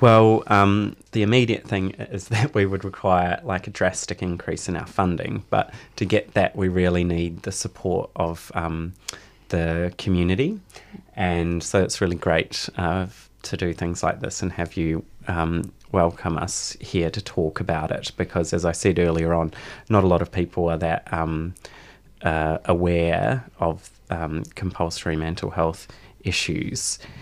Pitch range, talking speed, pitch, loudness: 85-100 Hz, 165 wpm, 90 Hz, -23 LUFS